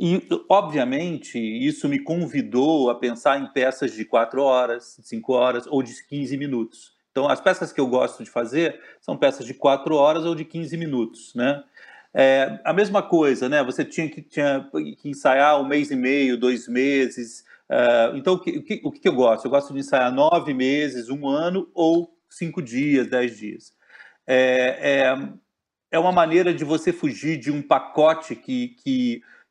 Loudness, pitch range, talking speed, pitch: -22 LUFS, 130-170 Hz, 180 wpm, 140 Hz